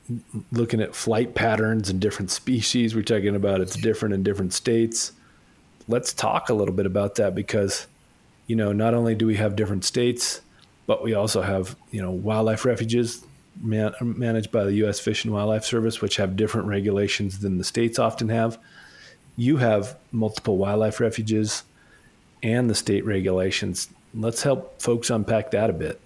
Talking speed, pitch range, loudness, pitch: 170 wpm, 100-115 Hz, -24 LUFS, 110 Hz